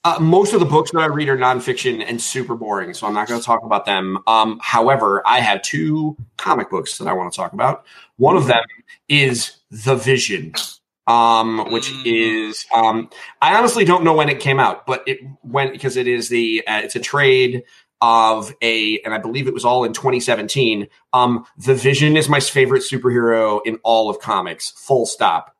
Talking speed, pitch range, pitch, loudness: 200 wpm, 115-140 Hz, 125 Hz, -17 LUFS